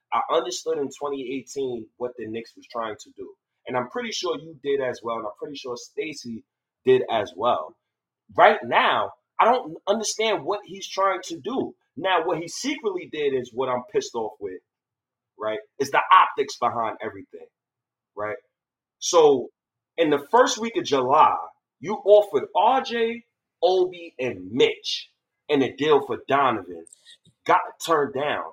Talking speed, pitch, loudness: 160 wpm, 230 Hz, -23 LUFS